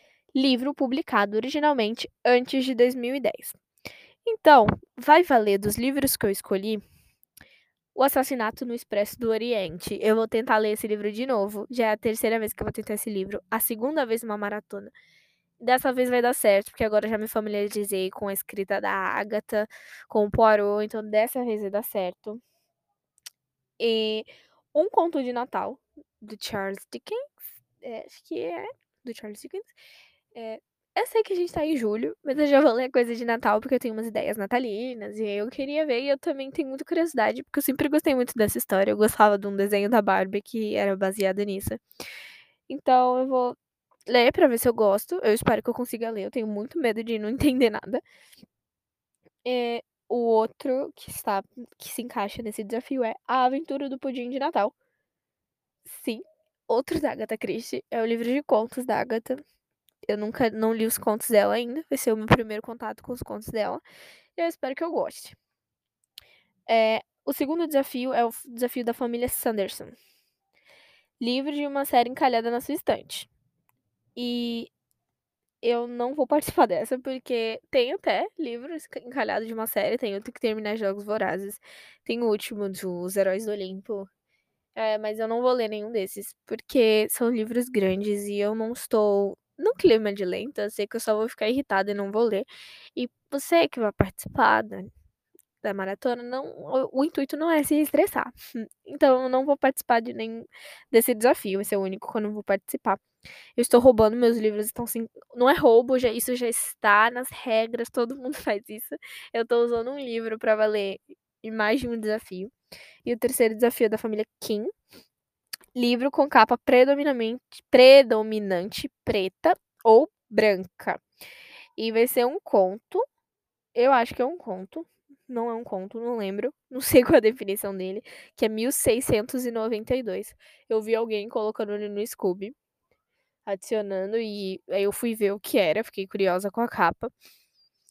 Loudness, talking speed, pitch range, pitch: -25 LUFS, 180 wpm, 215-265 Hz, 235 Hz